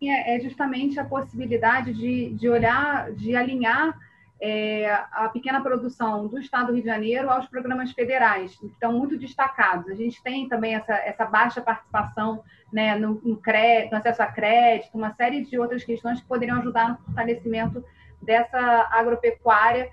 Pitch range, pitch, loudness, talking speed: 220-250 Hz, 235 Hz, -23 LUFS, 165 wpm